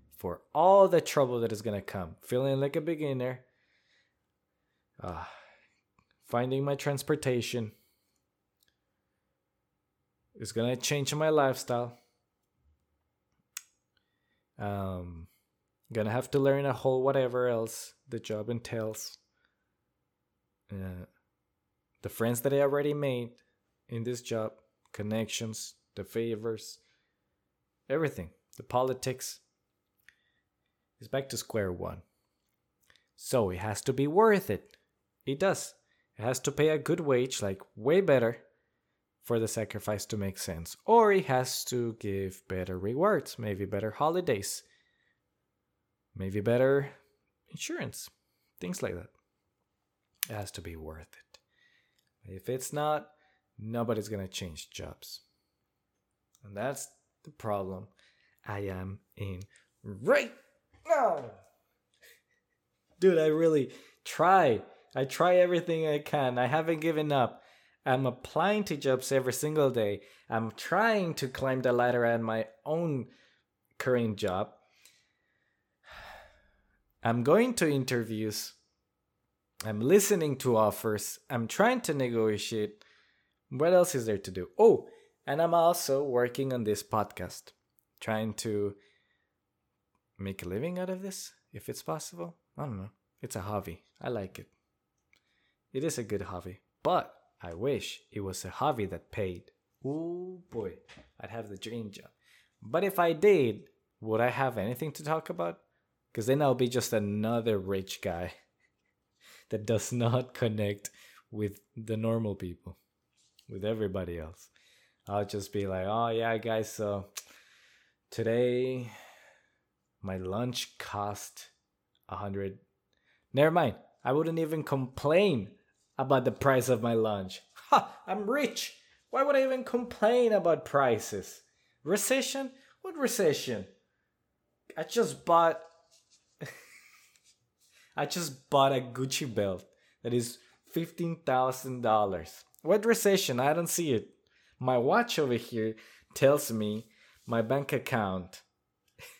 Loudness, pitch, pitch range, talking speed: -30 LUFS, 120 Hz, 105-145 Hz, 125 wpm